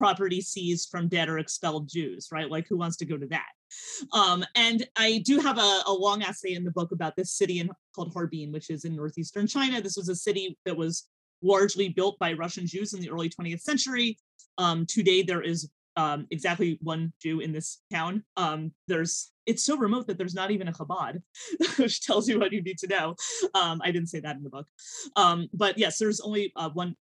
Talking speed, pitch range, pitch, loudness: 220 wpm, 165-205 Hz, 180 Hz, -28 LUFS